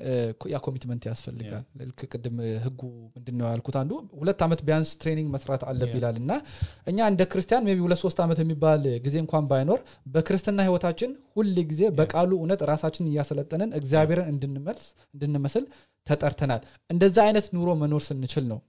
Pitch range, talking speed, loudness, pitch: 130-175 Hz, 145 wpm, -26 LUFS, 150 Hz